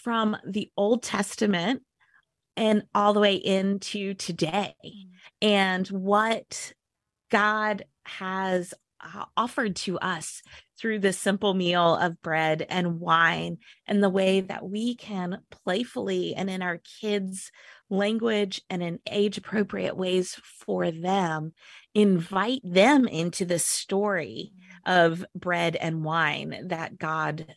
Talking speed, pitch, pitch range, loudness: 120 wpm, 190 Hz, 175-210 Hz, -26 LUFS